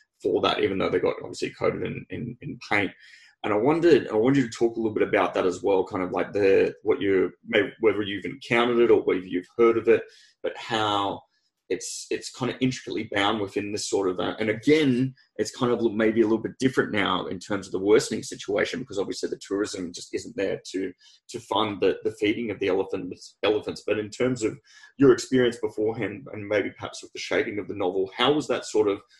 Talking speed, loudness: 230 wpm, -25 LUFS